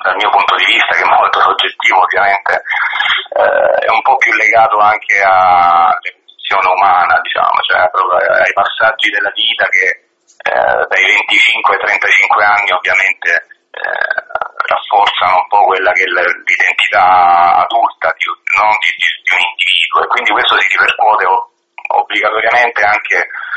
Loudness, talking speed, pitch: -10 LUFS, 135 wpm, 360 Hz